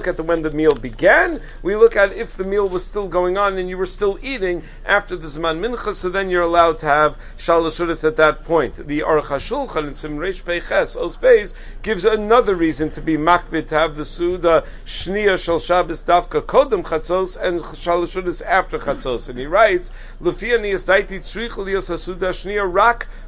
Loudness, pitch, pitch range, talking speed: -18 LUFS, 180 Hz, 160-200 Hz, 175 wpm